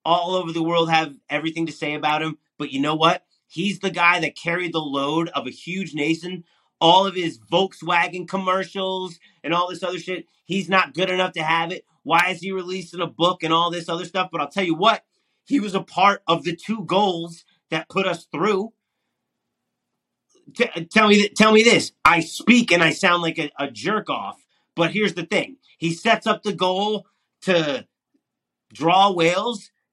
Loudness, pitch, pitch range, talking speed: -21 LUFS, 175 Hz, 165-195 Hz, 200 wpm